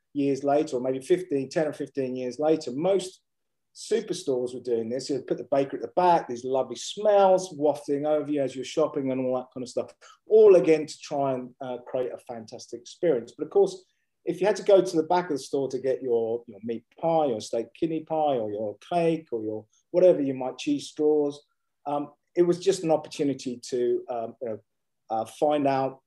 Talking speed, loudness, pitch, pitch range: 210 wpm, -26 LUFS, 145 Hz, 130-175 Hz